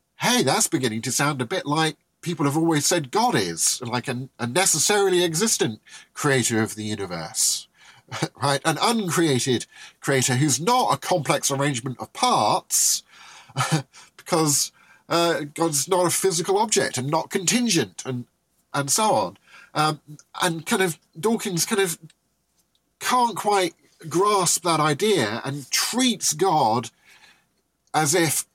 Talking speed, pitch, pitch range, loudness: 140 wpm, 160 Hz, 135-185 Hz, -22 LUFS